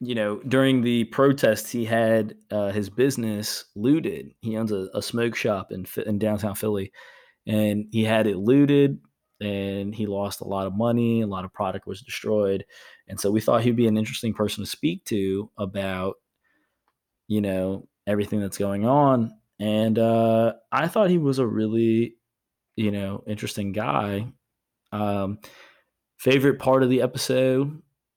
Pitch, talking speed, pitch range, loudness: 110 Hz, 160 wpm, 100-120 Hz, -24 LUFS